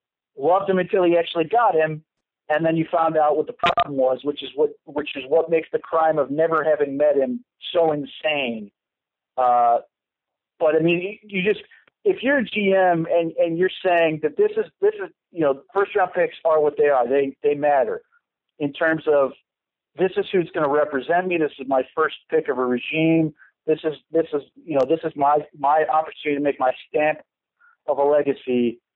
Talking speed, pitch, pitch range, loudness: 205 wpm, 155 Hz, 145-180 Hz, -21 LUFS